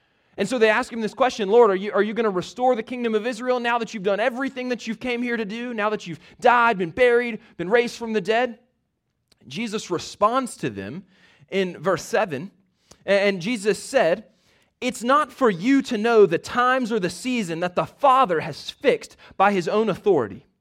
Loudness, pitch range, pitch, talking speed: -22 LUFS, 200-245 Hz, 225 Hz, 205 wpm